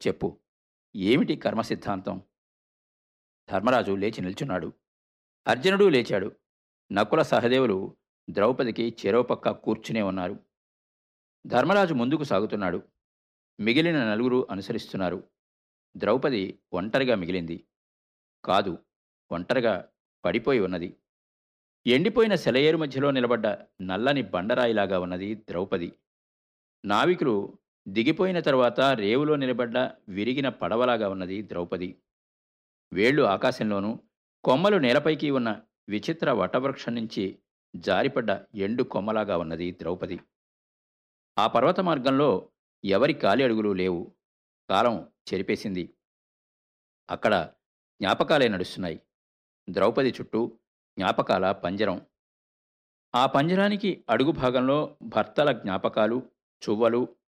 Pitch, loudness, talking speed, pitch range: 105 Hz, -26 LUFS, 85 wpm, 90-130 Hz